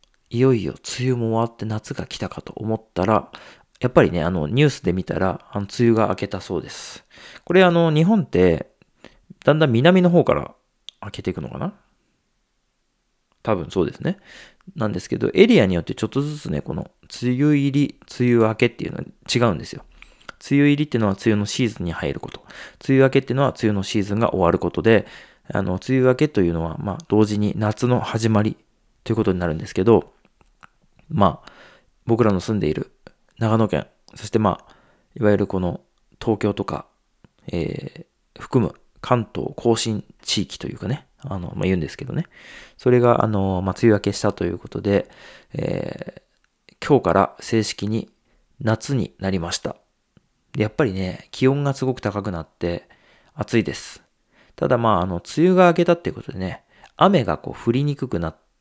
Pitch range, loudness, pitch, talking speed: 100-130 Hz, -21 LUFS, 110 Hz, 350 characters per minute